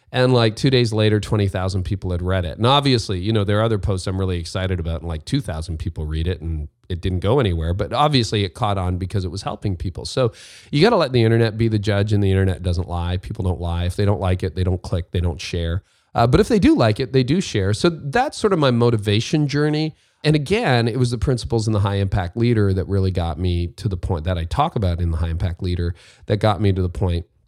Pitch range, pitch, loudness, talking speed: 90-120 Hz, 100 Hz, -20 LUFS, 265 wpm